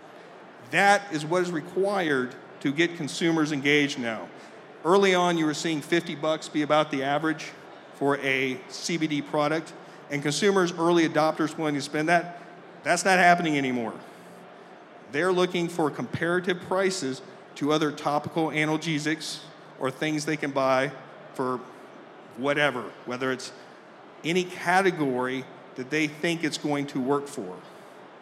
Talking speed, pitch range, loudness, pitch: 140 wpm, 140-175 Hz, -26 LUFS, 155 Hz